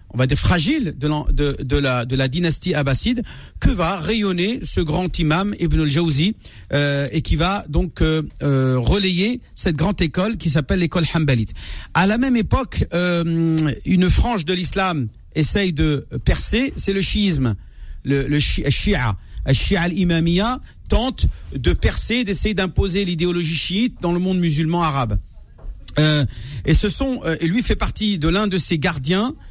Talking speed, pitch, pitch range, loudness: 165 wpm, 165 Hz, 140-190 Hz, -19 LUFS